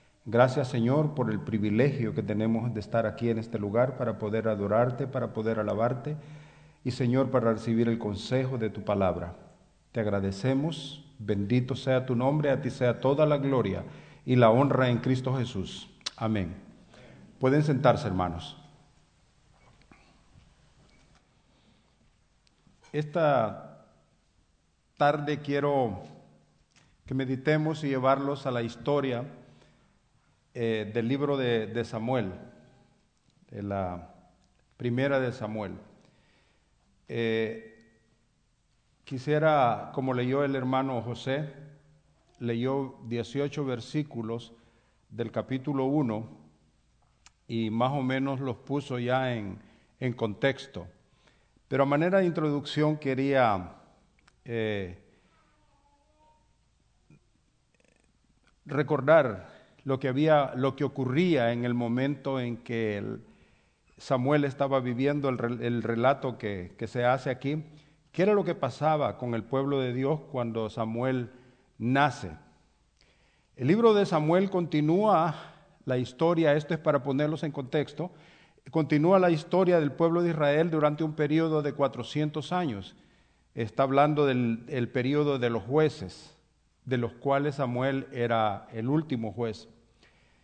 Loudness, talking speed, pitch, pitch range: -28 LUFS, 115 wpm, 130 Hz, 115-145 Hz